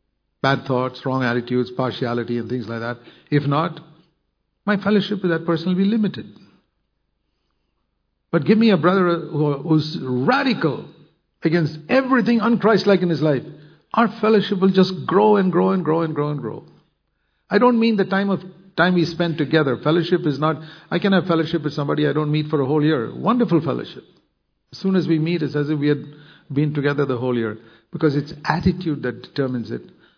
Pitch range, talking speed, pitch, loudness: 140-185 Hz, 185 wpm, 160 Hz, -20 LUFS